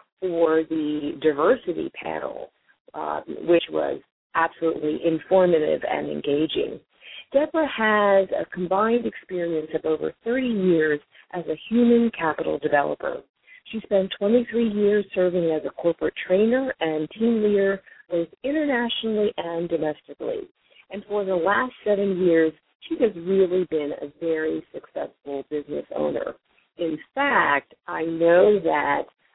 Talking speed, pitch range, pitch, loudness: 125 wpm, 160-225 Hz, 185 Hz, -23 LUFS